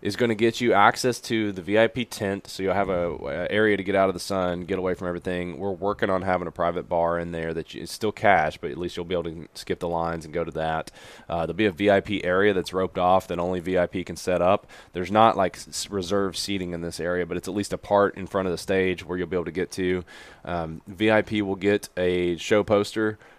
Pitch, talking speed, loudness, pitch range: 95 Hz, 260 wpm, -25 LUFS, 90-100 Hz